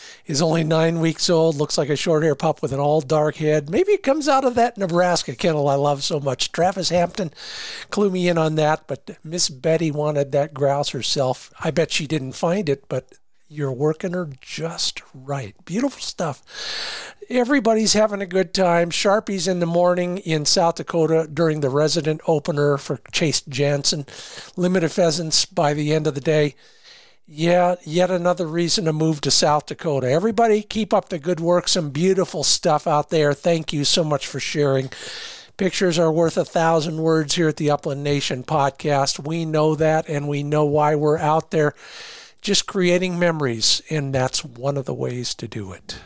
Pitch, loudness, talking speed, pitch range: 160 Hz, -20 LUFS, 185 wpm, 145-180 Hz